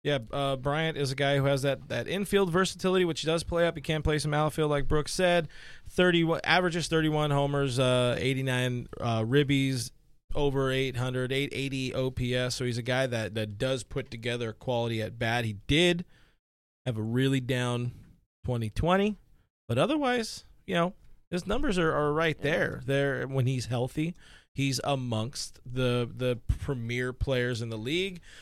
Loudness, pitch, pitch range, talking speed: -29 LUFS, 135 Hz, 125-155 Hz, 165 wpm